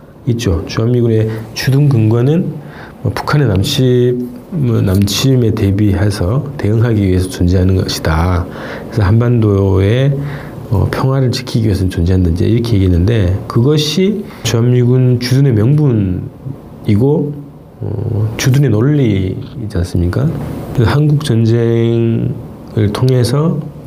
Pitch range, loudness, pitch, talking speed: 100-135 Hz, -13 LUFS, 115 Hz, 255 characters per minute